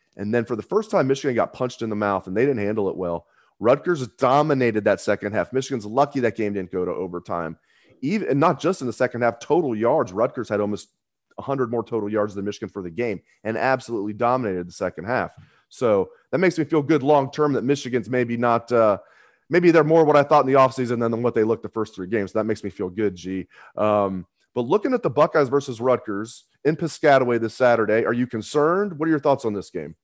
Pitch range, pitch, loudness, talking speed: 105-140 Hz, 120 Hz, -22 LUFS, 235 wpm